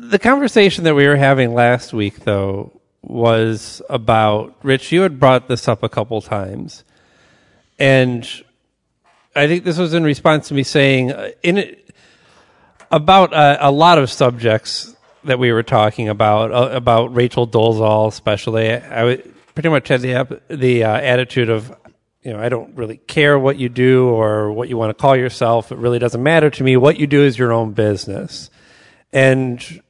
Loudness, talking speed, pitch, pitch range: -15 LUFS, 175 wpm, 125 Hz, 115-145 Hz